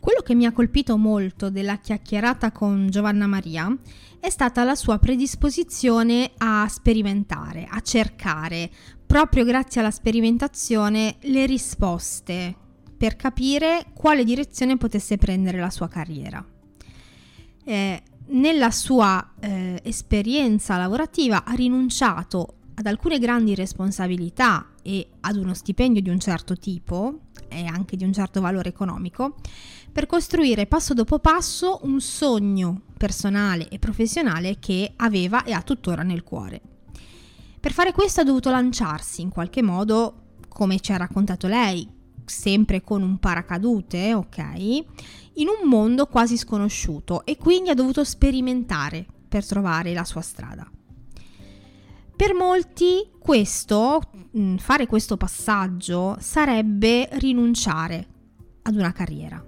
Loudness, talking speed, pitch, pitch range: -22 LUFS, 125 wpm, 215 Hz, 185-255 Hz